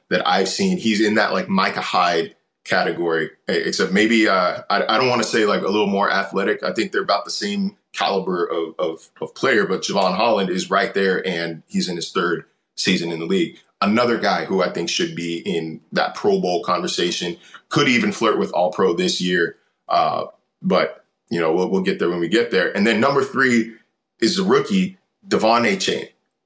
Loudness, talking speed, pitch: -20 LUFS, 210 wpm, 110 Hz